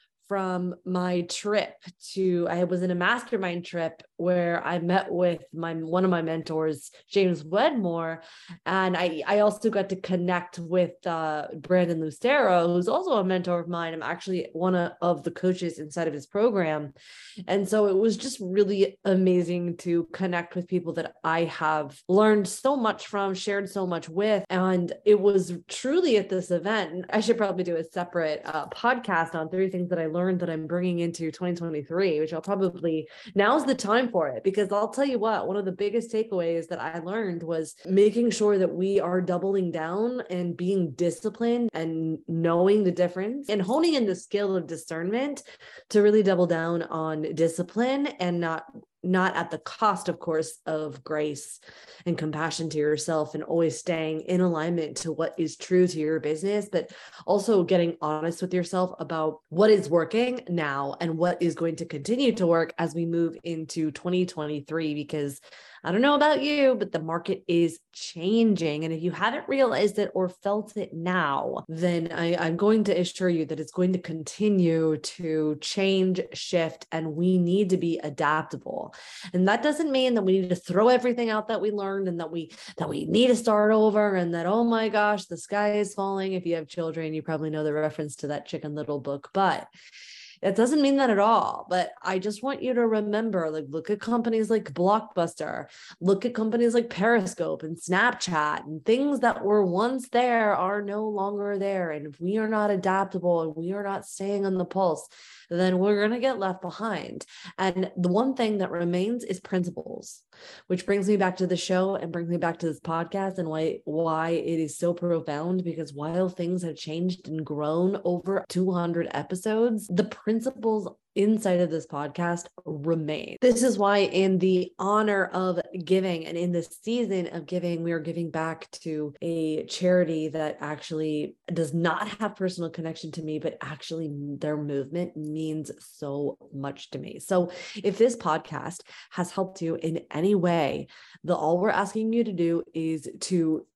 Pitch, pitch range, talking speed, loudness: 180 Hz, 165-205 Hz, 185 wpm, -26 LUFS